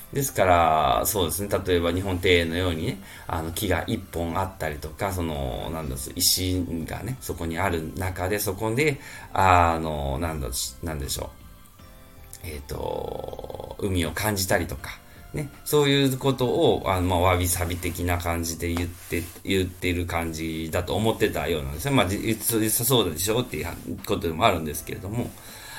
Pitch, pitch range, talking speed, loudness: 90 Hz, 85-105 Hz, 340 characters per minute, -25 LUFS